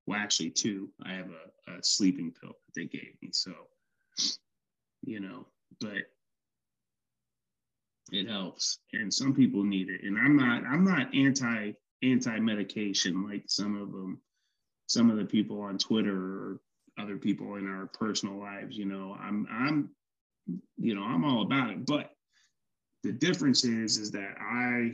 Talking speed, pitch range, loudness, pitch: 160 wpm, 100-145 Hz, -30 LUFS, 105 Hz